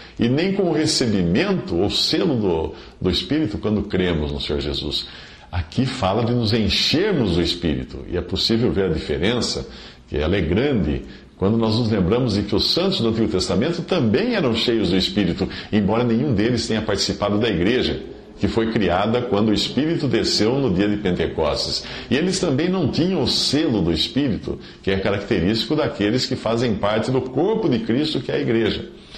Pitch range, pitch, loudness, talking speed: 90-120 Hz, 105 Hz, -20 LUFS, 185 wpm